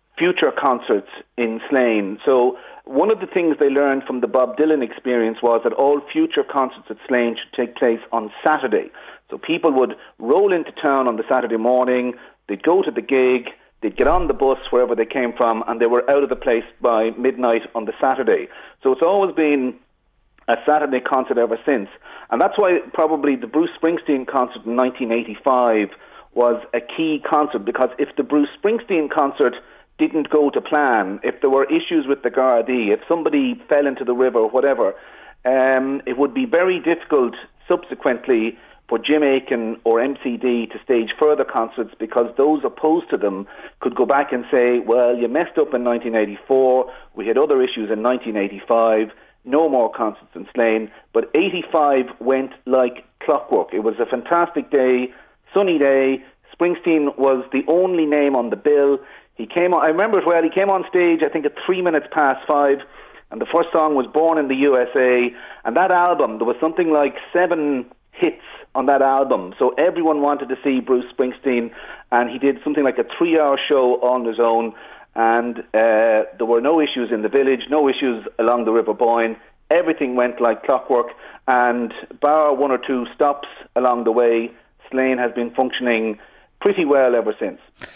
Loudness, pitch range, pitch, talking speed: -19 LUFS, 120-155 Hz, 135 Hz, 180 wpm